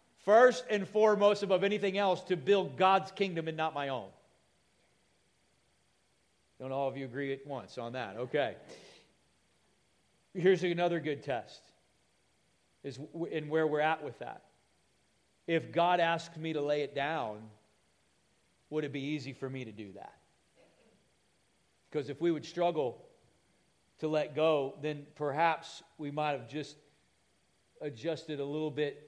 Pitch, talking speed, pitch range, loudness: 150 Hz, 145 wpm, 135-170 Hz, -32 LUFS